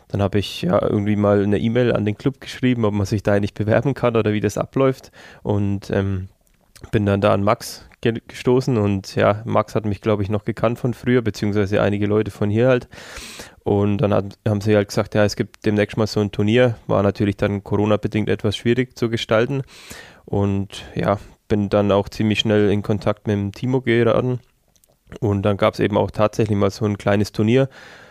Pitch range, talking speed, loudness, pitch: 100-115 Hz, 205 wpm, -20 LUFS, 105 Hz